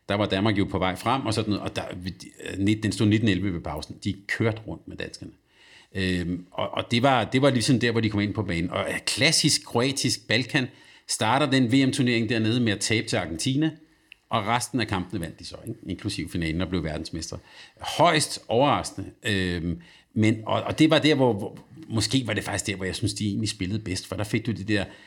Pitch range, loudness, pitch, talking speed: 95-120 Hz, -25 LUFS, 110 Hz, 220 wpm